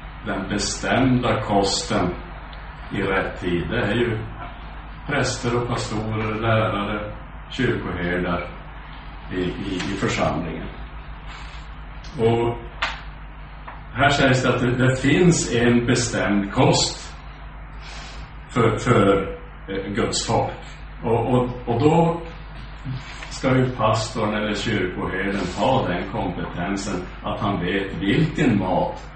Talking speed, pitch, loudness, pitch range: 105 wpm, 110 Hz, -22 LUFS, 100-125 Hz